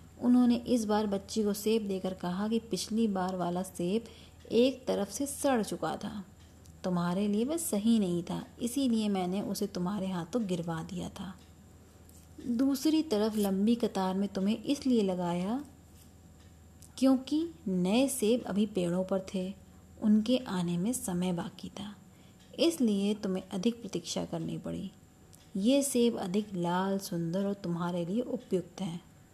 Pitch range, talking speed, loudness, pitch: 180-230 Hz, 145 wpm, -31 LUFS, 200 Hz